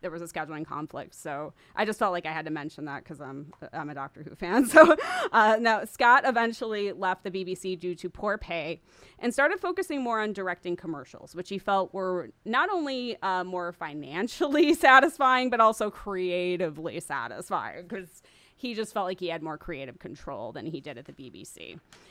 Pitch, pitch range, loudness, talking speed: 185 Hz, 165-225 Hz, -26 LUFS, 195 wpm